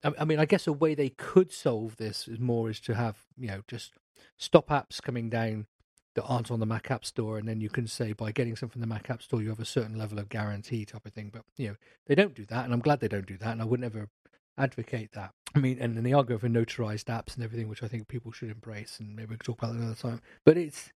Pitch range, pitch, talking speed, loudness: 110-125 Hz, 115 Hz, 285 wpm, -30 LUFS